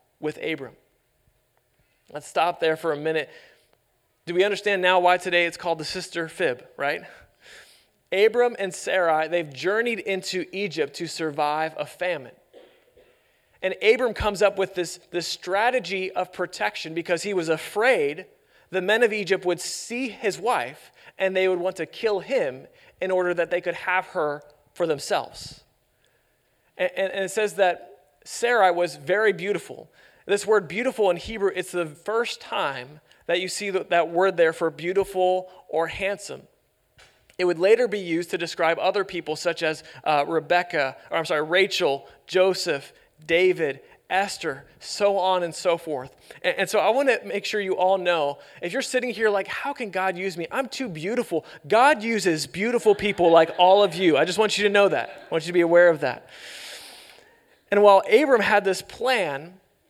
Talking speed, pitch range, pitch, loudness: 175 wpm, 165-205 Hz, 185 Hz, -23 LUFS